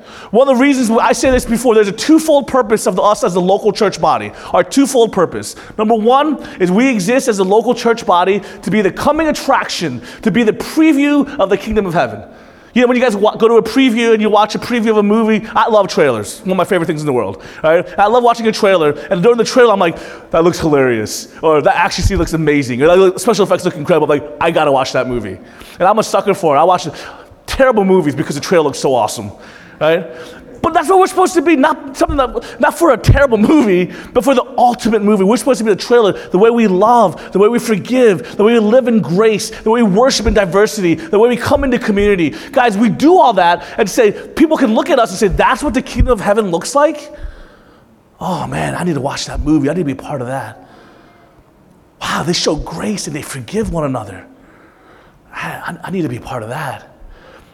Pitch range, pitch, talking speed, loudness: 185-255 Hz, 220 Hz, 245 wpm, -13 LUFS